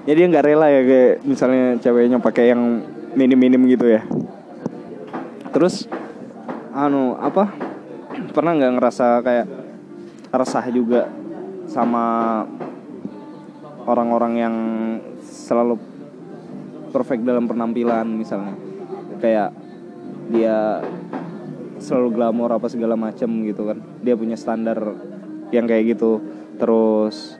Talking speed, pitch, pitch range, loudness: 100 wpm, 120 Hz, 115-125 Hz, -18 LUFS